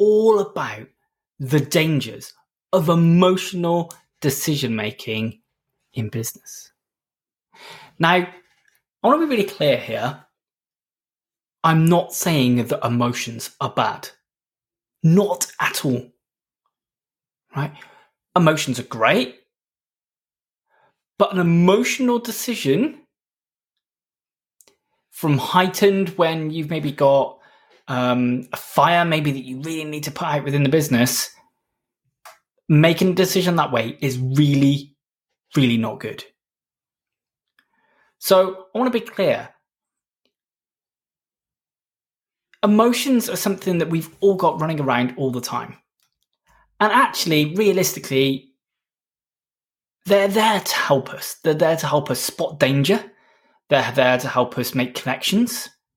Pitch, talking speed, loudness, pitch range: 160 Hz, 115 wpm, -20 LUFS, 135-185 Hz